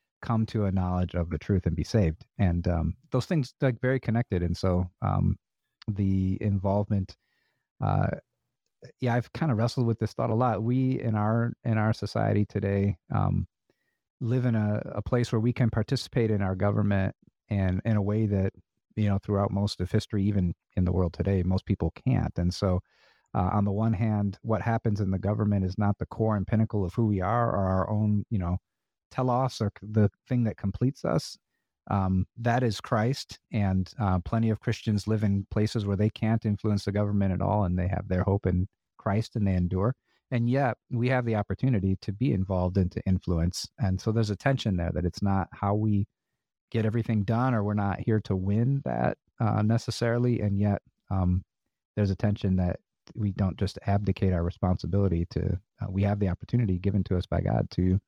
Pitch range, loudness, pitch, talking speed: 95-115 Hz, -28 LUFS, 105 Hz, 200 wpm